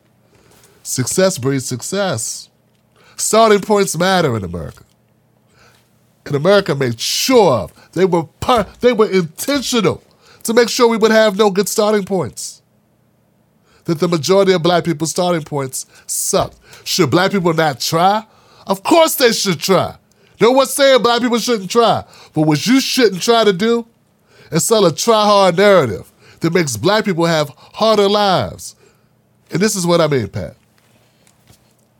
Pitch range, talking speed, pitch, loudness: 140-215 Hz, 155 wpm, 185 Hz, -14 LUFS